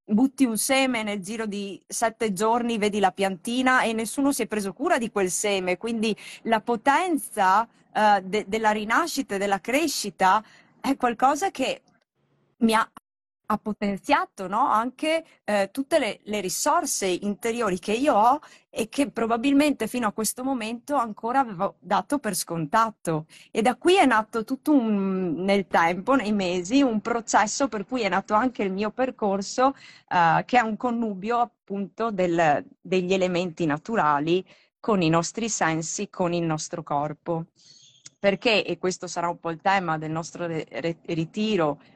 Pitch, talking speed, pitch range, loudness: 215 Hz, 155 wpm, 185-245 Hz, -24 LUFS